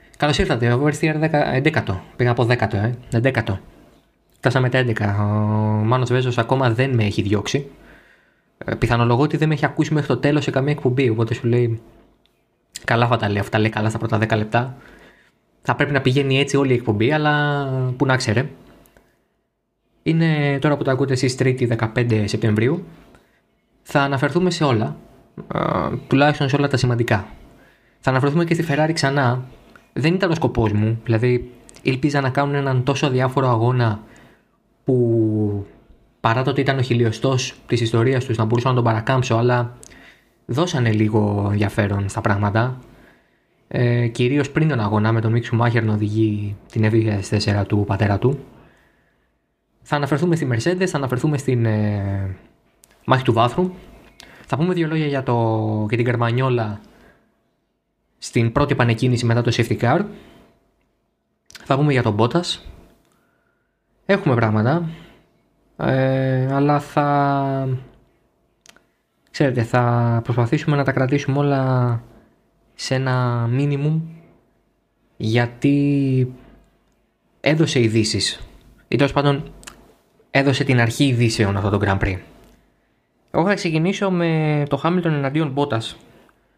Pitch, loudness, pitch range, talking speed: 125 Hz, -19 LUFS, 115-140 Hz, 140 wpm